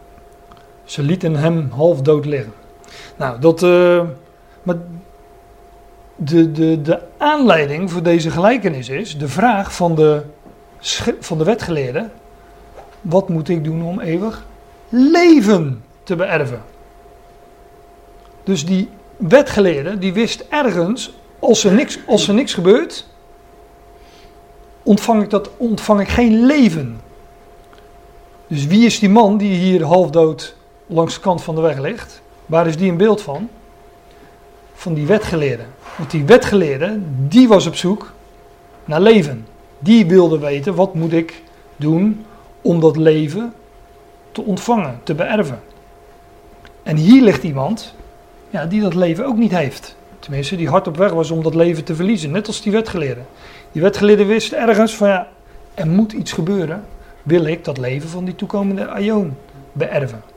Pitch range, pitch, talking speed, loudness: 160-210 Hz, 180 Hz, 145 wpm, -15 LUFS